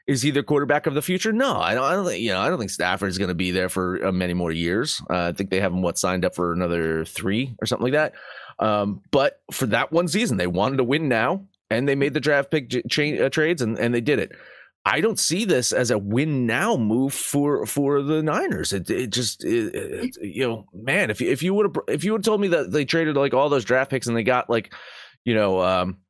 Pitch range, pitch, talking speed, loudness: 95-150 Hz, 130 Hz, 270 wpm, -22 LUFS